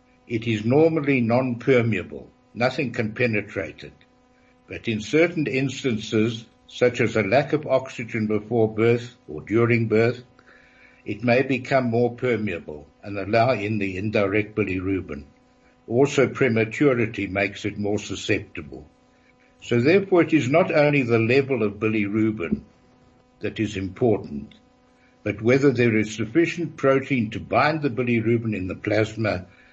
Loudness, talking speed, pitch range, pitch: -22 LUFS, 135 wpm, 105-130 Hz, 115 Hz